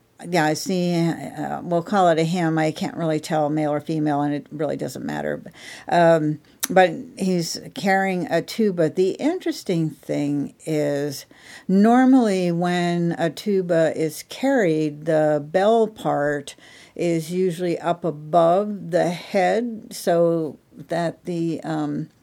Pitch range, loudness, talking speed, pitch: 155-185 Hz, -22 LUFS, 135 wpm, 170 Hz